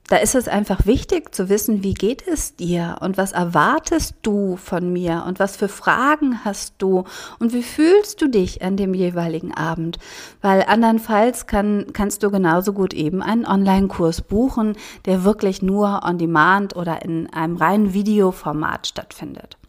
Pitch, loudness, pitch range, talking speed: 195 Hz, -19 LUFS, 180-215 Hz, 160 wpm